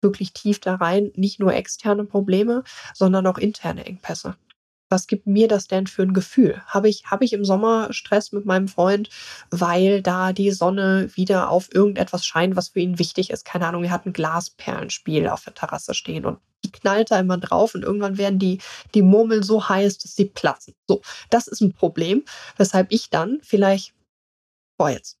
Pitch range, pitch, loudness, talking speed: 185-210 Hz, 195 Hz, -21 LUFS, 190 wpm